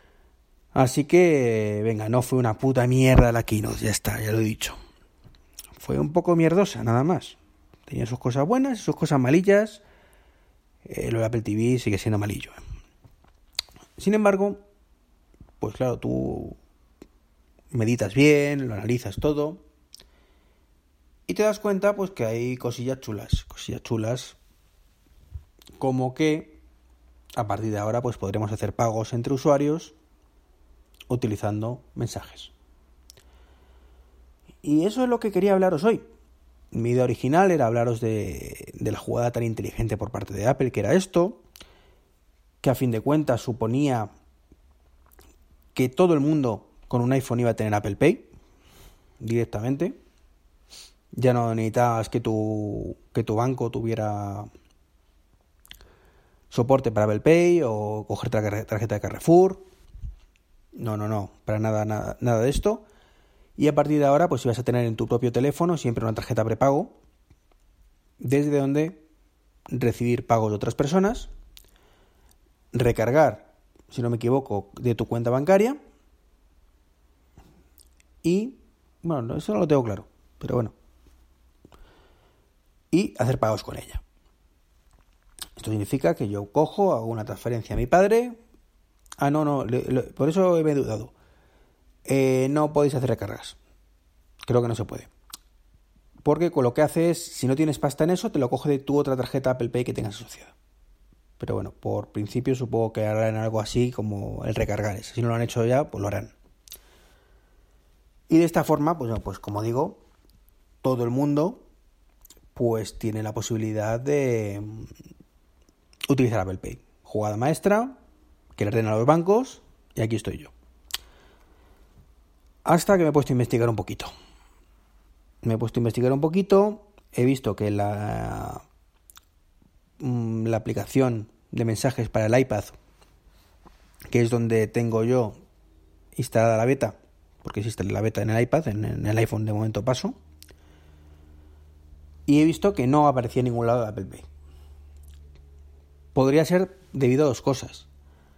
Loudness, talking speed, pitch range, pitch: -24 LUFS, 150 wpm, 80-135 Hz, 110 Hz